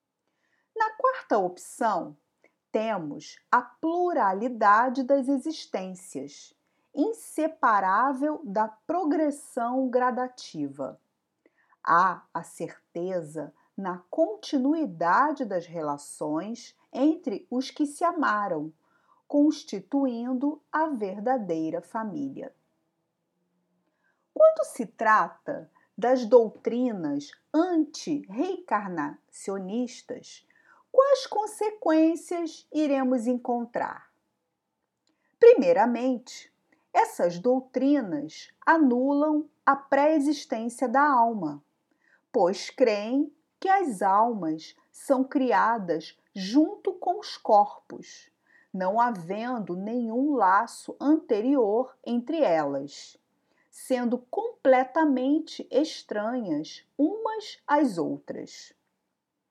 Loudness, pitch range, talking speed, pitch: -26 LUFS, 225-310 Hz, 70 wpm, 265 Hz